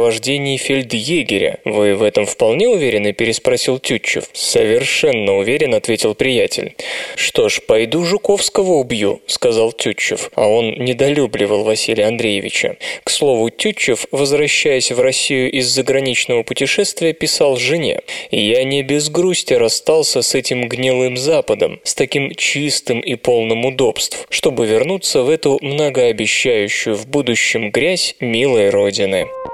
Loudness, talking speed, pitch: -15 LUFS, 125 wpm, 205 Hz